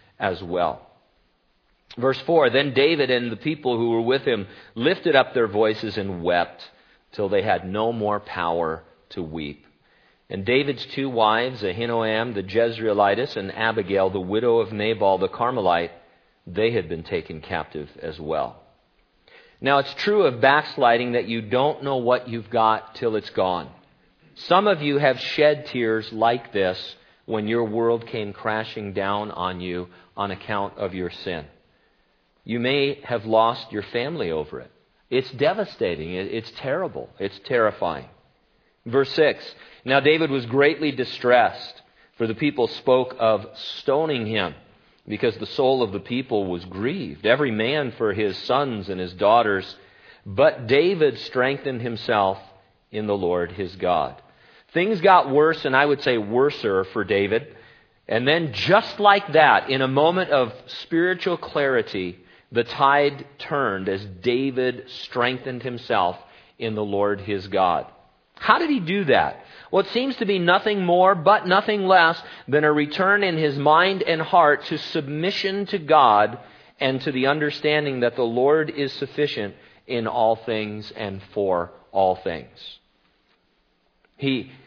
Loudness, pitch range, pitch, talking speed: -22 LUFS, 105-145 Hz, 120 Hz, 150 wpm